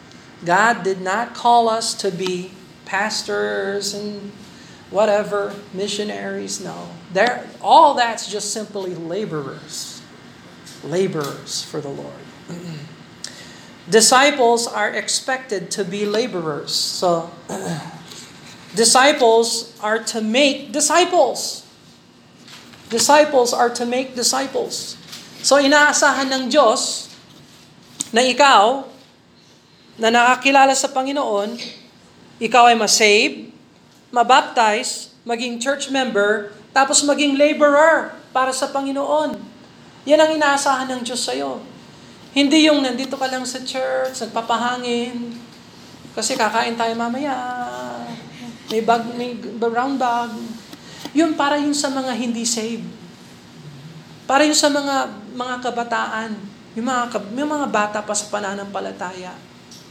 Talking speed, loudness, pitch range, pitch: 105 wpm, -18 LUFS, 205-265 Hz, 235 Hz